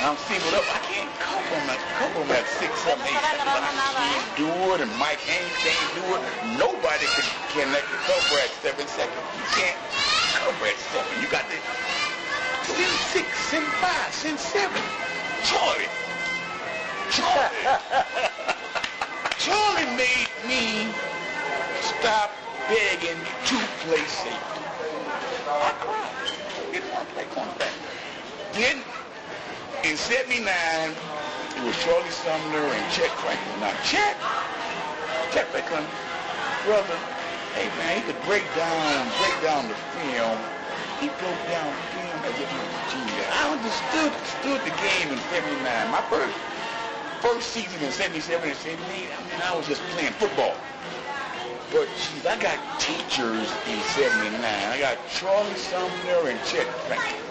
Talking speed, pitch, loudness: 140 wpm, 245 Hz, -25 LUFS